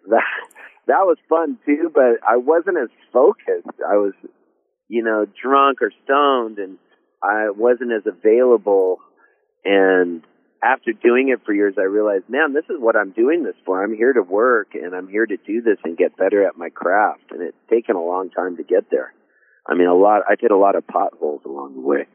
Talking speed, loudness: 205 wpm, -18 LUFS